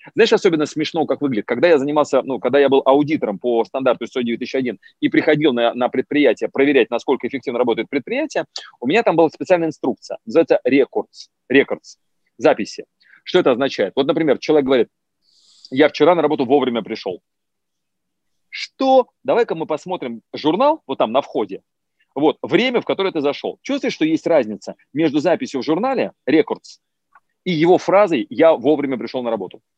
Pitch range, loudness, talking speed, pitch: 130-190 Hz, -18 LUFS, 165 wpm, 150 Hz